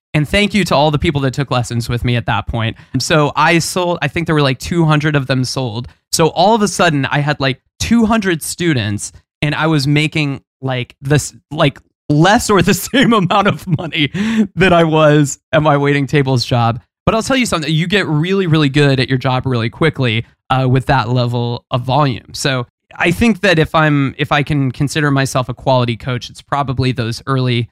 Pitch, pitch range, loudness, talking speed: 145 Hz, 130-165 Hz, -14 LUFS, 215 wpm